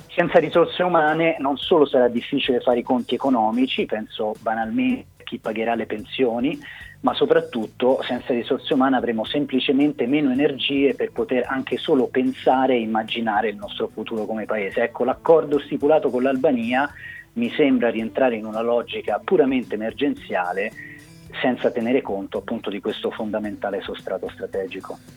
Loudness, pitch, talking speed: -22 LUFS, 140 Hz, 145 wpm